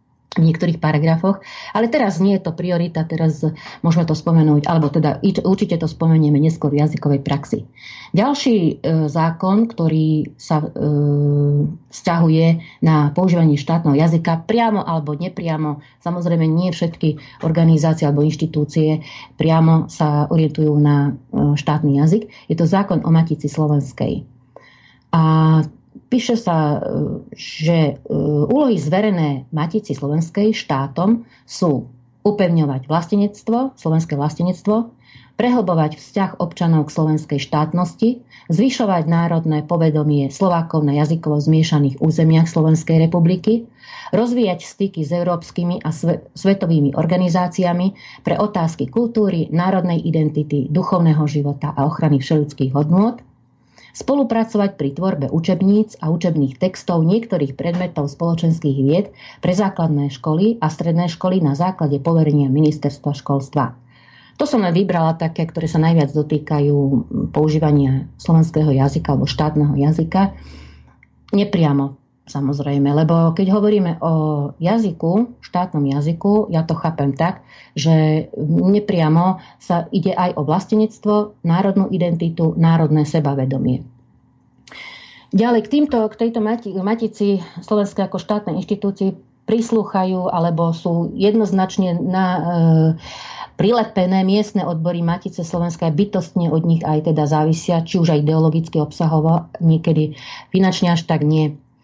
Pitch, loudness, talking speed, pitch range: 165 Hz, -17 LUFS, 115 wpm, 150-185 Hz